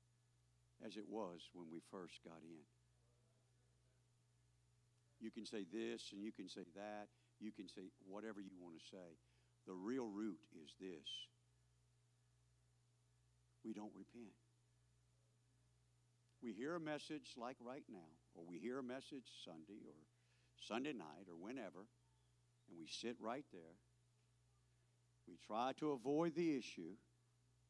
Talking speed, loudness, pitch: 135 wpm, -51 LUFS, 90 Hz